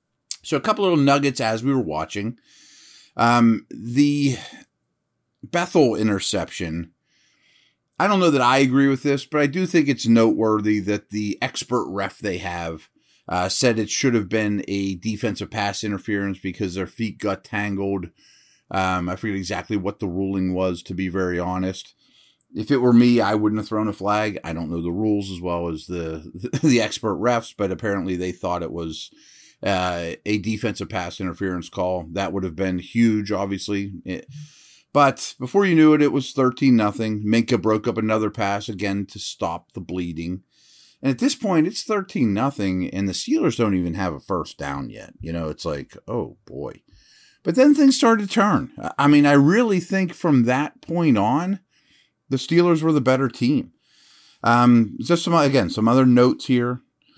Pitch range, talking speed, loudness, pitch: 95-135 Hz, 180 wpm, -21 LUFS, 110 Hz